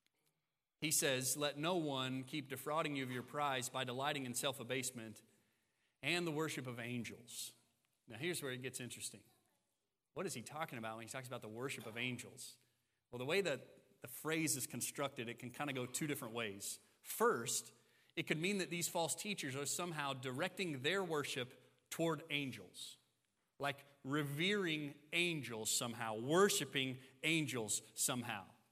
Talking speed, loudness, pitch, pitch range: 165 wpm, -41 LUFS, 130 Hz, 120-150 Hz